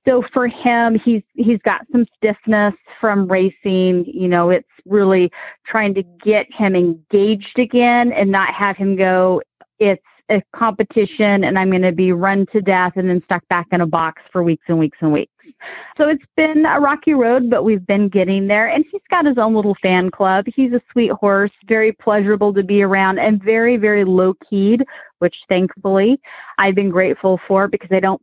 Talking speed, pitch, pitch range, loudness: 195 wpm, 205 Hz, 185-230 Hz, -16 LUFS